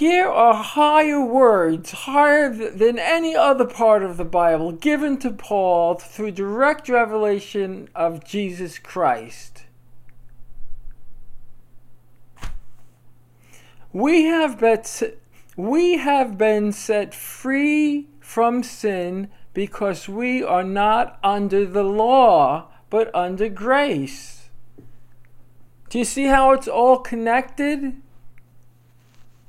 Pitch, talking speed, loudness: 200 Hz, 90 wpm, -19 LUFS